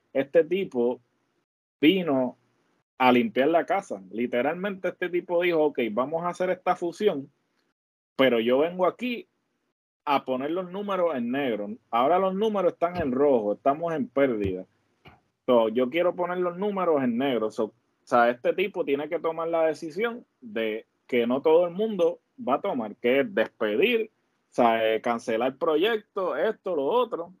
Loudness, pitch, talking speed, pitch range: -26 LUFS, 165 Hz, 160 wpm, 125-185 Hz